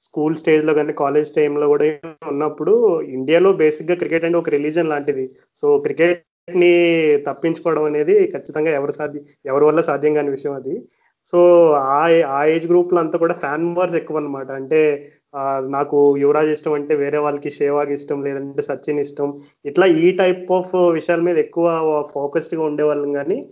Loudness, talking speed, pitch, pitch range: -17 LUFS, 165 wpm, 150 Hz, 145-170 Hz